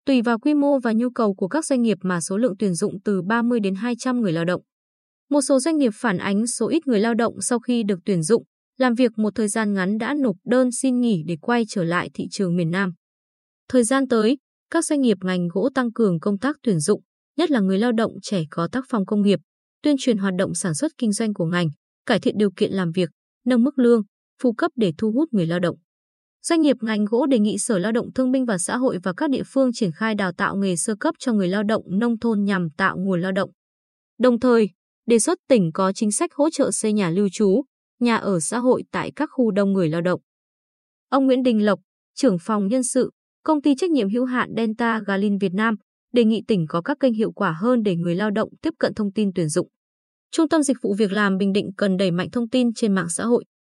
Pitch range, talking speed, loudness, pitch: 195-250 Hz, 250 wpm, -21 LUFS, 220 Hz